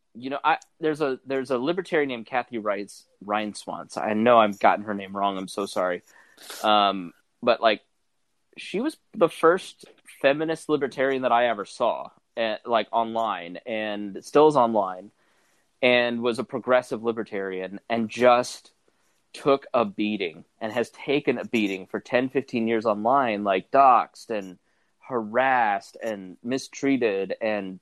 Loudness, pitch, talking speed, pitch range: -24 LUFS, 115 Hz, 150 wpm, 105-130 Hz